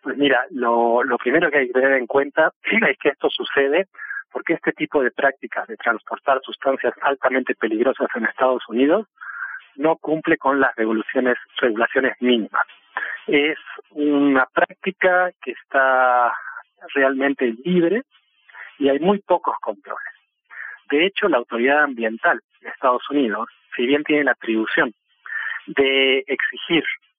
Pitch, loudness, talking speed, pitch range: 140 Hz, -20 LUFS, 135 wpm, 125-160 Hz